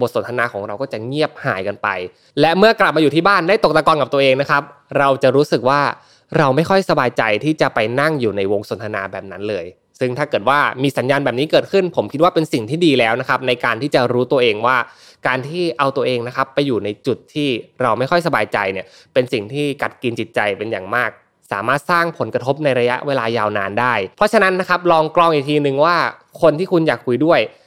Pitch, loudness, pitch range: 140 Hz, -17 LUFS, 120-160 Hz